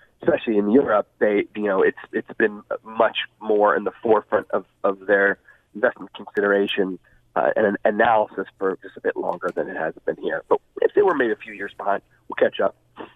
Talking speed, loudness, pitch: 200 wpm, -22 LUFS, 115 Hz